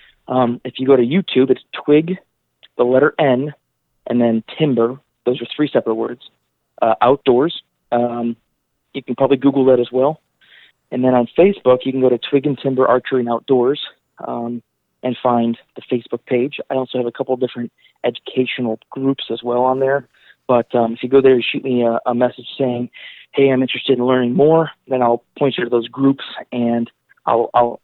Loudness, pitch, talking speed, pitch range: -17 LUFS, 125 Hz, 195 wpm, 120-135 Hz